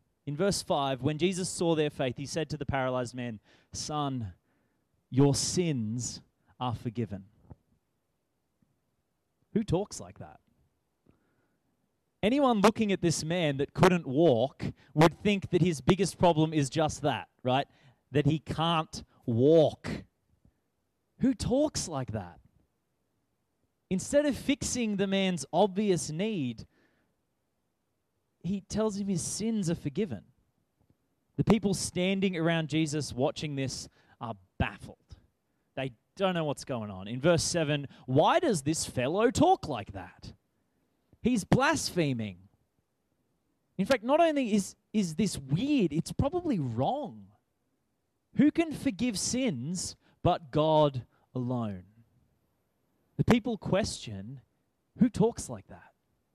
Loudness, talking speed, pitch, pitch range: -29 LUFS, 120 wpm, 155 Hz, 130-190 Hz